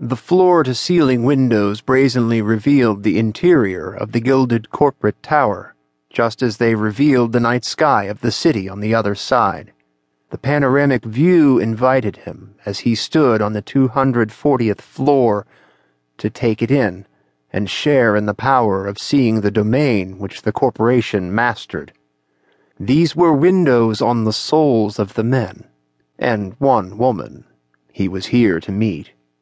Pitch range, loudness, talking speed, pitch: 100-130 Hz, -16 LUFS, 155 wpm, 115 Hz